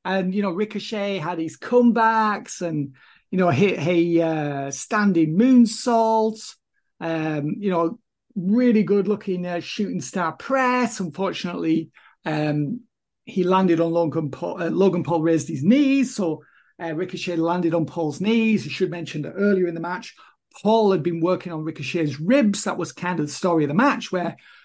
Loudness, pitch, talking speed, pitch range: -22 LUFS, 180 Hz, 170 wpm, 165-215 Hz